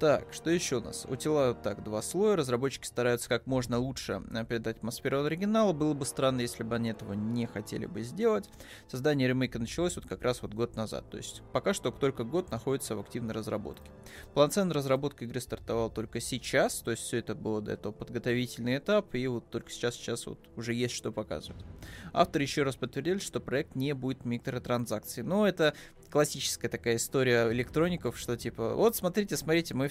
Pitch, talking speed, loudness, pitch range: 120 Hz, 190 wpm, -32 LUFS, 115-145 Hz